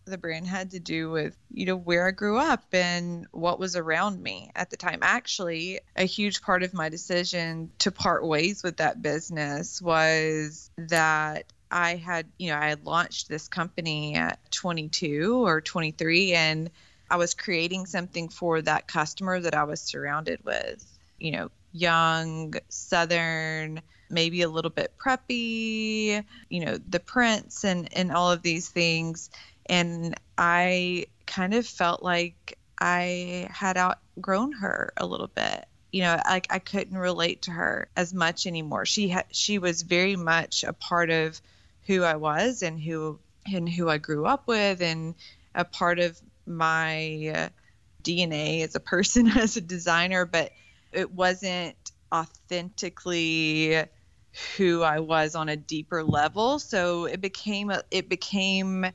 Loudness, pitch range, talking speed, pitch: -26 LUFS, 160-185 Hz, 155 wpm, 175 Hz